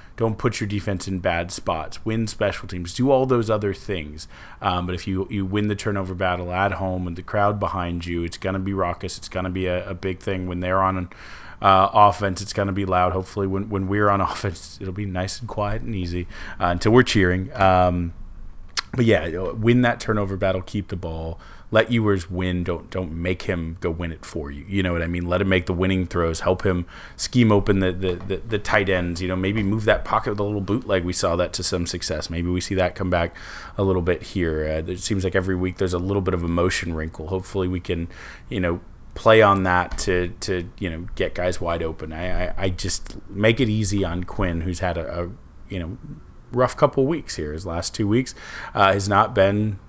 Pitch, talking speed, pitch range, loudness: 95 Hz, 235 wpm, 90-100 Hz, -23 LUFS